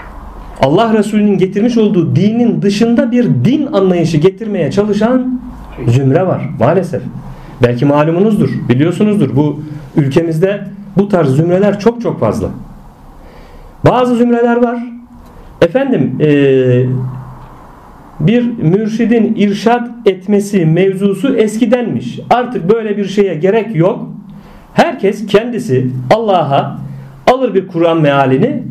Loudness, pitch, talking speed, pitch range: -12 LUFS, 195 Hz, 100 wpm, 155-225 Hz